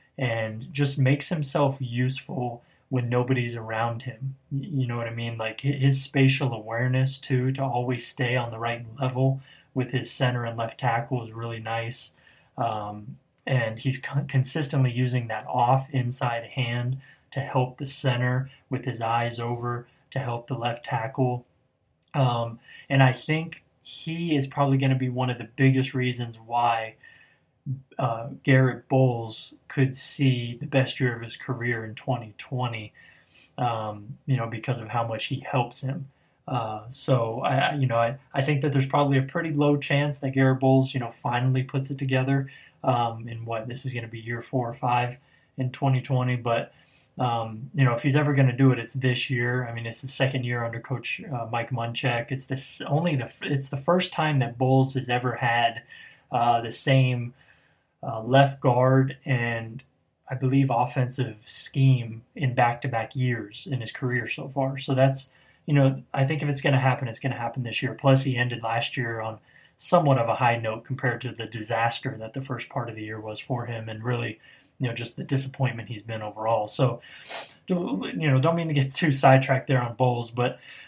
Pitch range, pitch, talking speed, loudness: 120-135 Hz, 130 Hz, 190 wpm, -26 LUFS